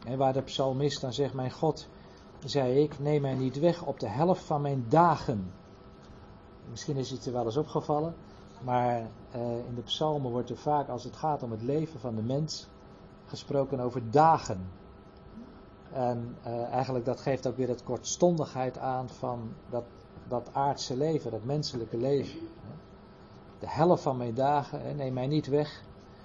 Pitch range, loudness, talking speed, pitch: 120-145 Hz, -31 LUFS, 165 wpm, 130 Hz